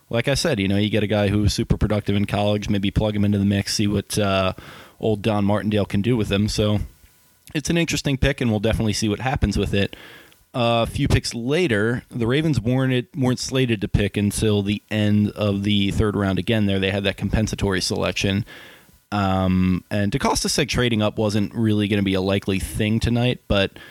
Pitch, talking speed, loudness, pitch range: 105 Hz, 215 wpm, -21 LUFS, 100-115 Hz